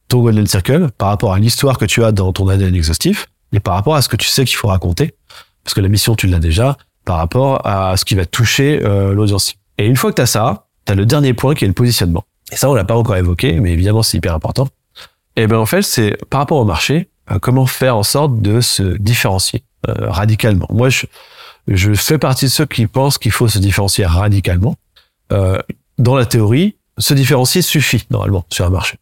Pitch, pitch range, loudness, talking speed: 110 Hz, 100-130 Hz, -14 LUFS, 225 wpm